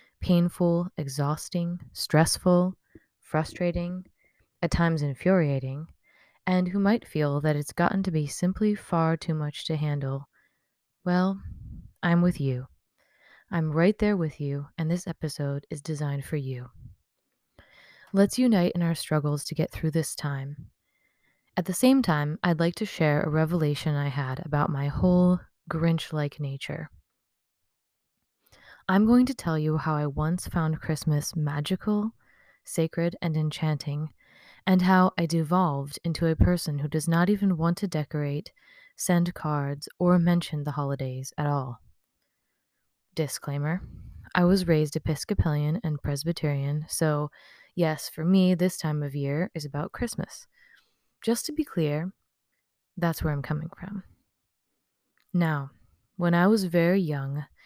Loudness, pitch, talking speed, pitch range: -27 LUFS, 160 Hz, 140 wpm, 150-180 Hz